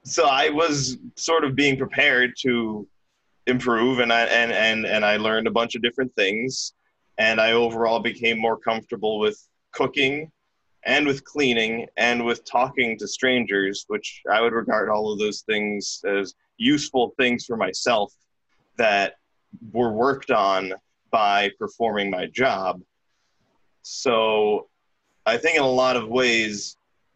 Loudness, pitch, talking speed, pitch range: -22 LUFS, 115 Hz, 145 wpm, 110-130 Hz